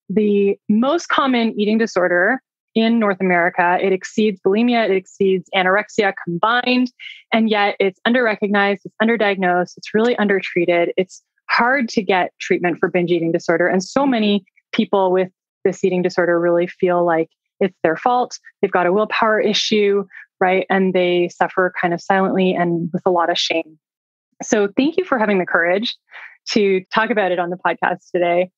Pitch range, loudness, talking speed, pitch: 180-220 Hz, -18 LUFS, 170 wpm, 195 Hz